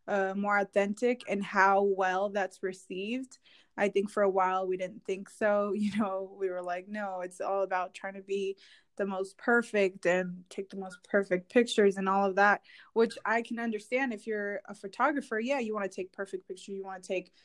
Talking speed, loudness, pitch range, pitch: 210 wpm, -31 LUFS, 190-210 Hz, 200 Hz